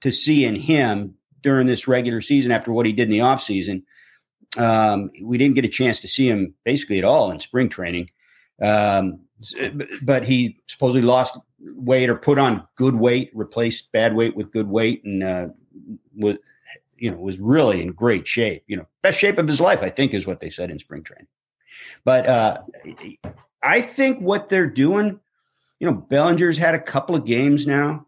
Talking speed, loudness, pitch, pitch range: 190 wpm, -20 LUFS, 125 Hz, 105-140 Hz